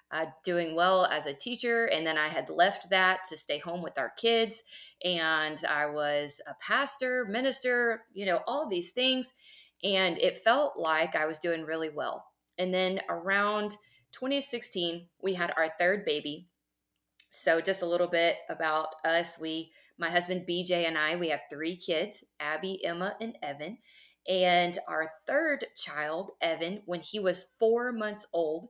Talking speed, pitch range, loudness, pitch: 165 wpm, 160-210 Hz, -30 LUFS, 175 Hz